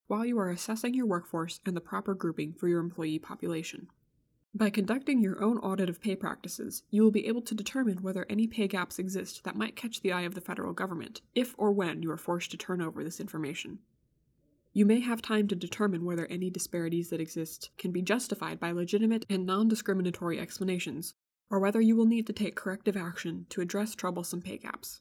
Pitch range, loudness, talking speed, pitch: 170-215 Hz, -32 LUFS, 210 wpm, 190 Hz